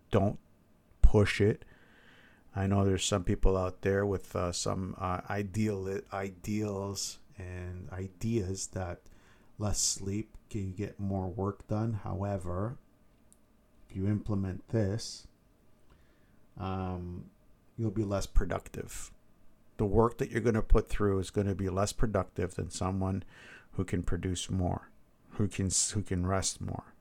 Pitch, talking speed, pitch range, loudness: 100 Hz, 140 wpm, 95-105 Hz, -33 LUFS